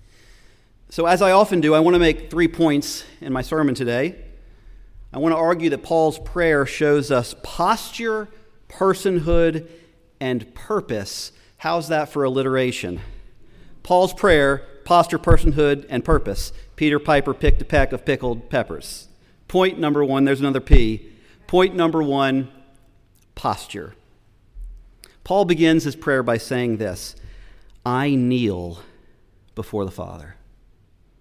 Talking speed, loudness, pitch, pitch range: 130 wpm, -20 LUFS, 135 Hz, 110-165 Hz